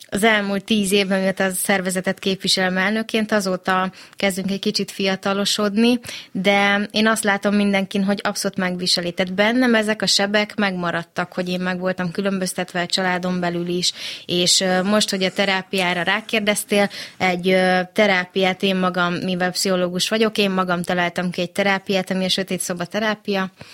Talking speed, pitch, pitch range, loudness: 150 wpm, 190 Hz, 185-205 Hz, -19 LUFS